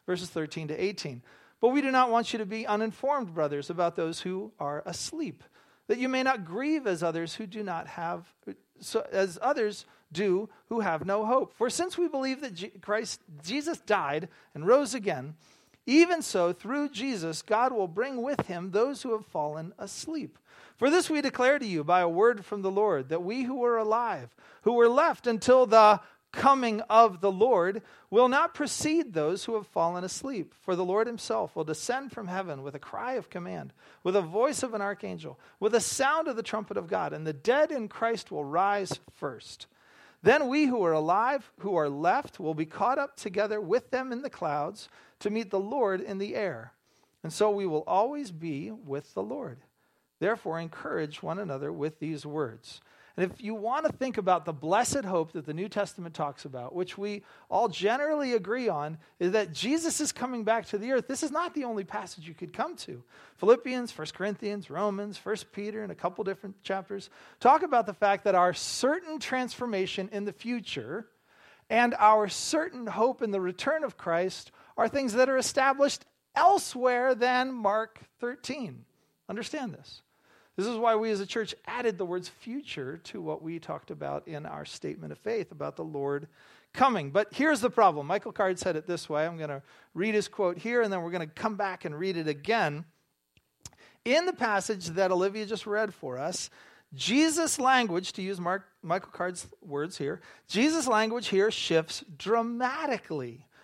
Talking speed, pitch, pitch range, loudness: 195 wpm, 210 Hz, 180-250 Hz, -29 LUFS